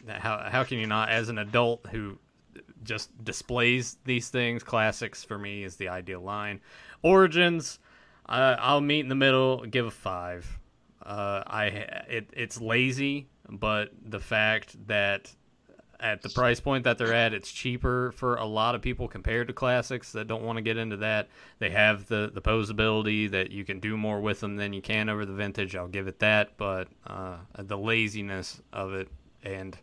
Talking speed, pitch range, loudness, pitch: 185 wpm, 100-120 Hz, -28 LUFS, 110 Hz